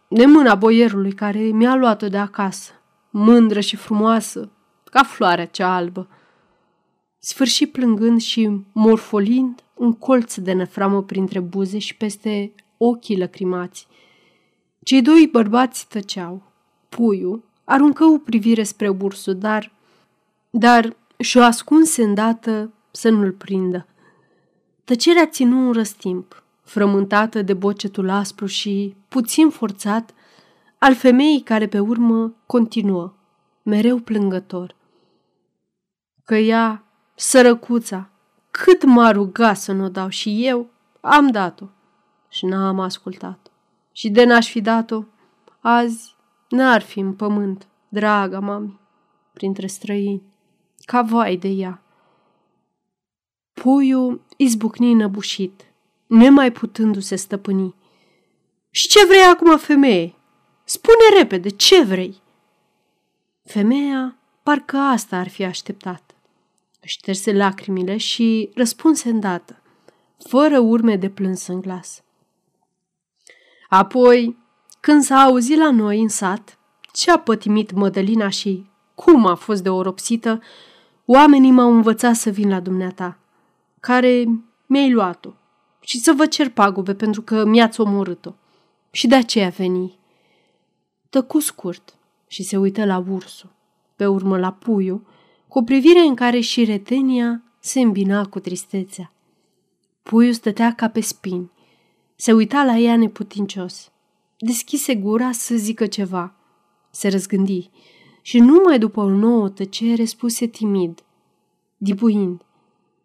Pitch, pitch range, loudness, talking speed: 215 Hz, 195-240 Hz, -16 LUFS, 120 wpm